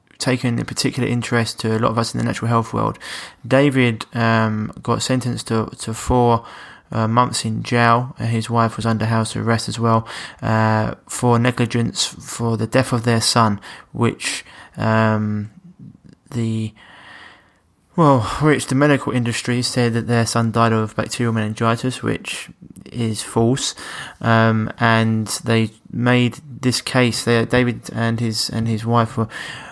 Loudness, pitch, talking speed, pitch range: -19 LUFS, 115 Hz, 155 wpm, 110-125 Hz